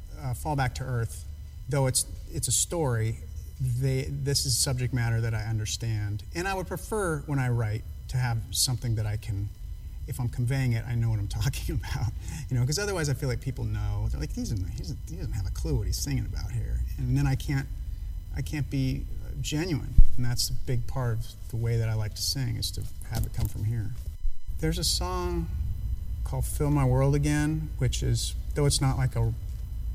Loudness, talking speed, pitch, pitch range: -29 LUFS, 215 wpm, 115 Hz, 95-130 Hz